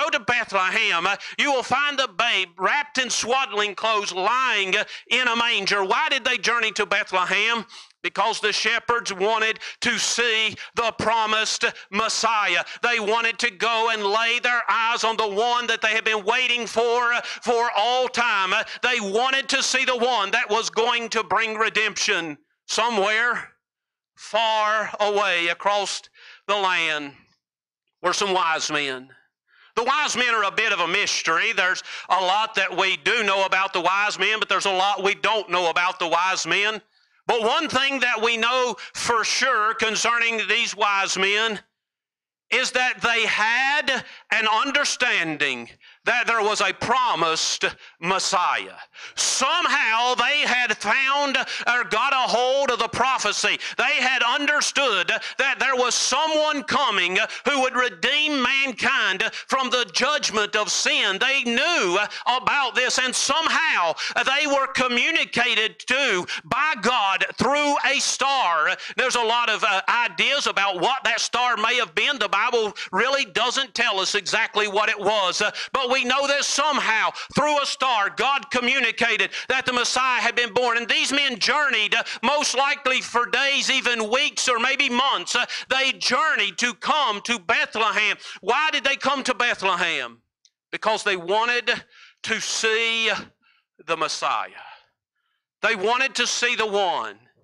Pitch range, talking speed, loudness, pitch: 210-255 Hz, 150 wpm, -21 LUFS, 235 Hz